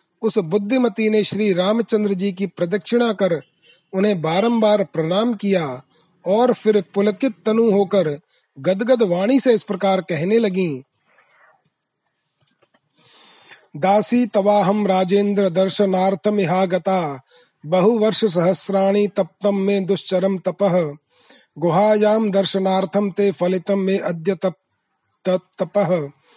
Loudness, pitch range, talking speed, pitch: -18 LUFS, 185-210 Hz, 100 wpm, 195 Hz